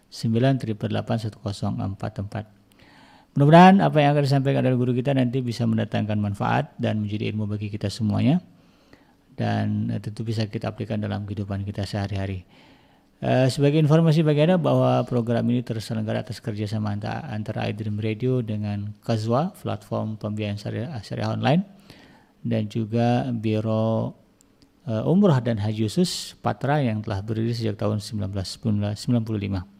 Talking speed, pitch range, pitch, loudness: 125 wpm, 105-125 Hz, 110 Hz, -24 LUFS